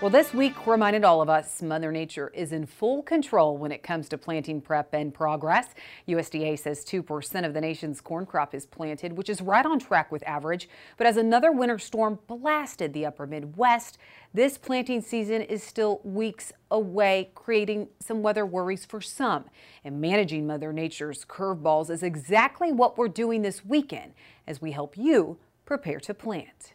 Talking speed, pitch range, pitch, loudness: 175 wpm, 155-225 Hz, 190 Hz, -27 LUFS